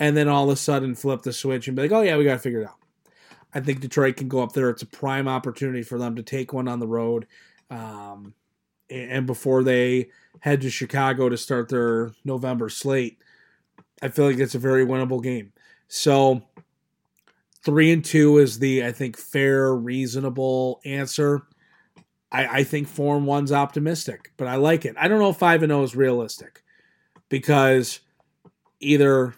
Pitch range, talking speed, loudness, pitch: 125-145 Hz, 185 wpm, -22 LUFS, 135 Hz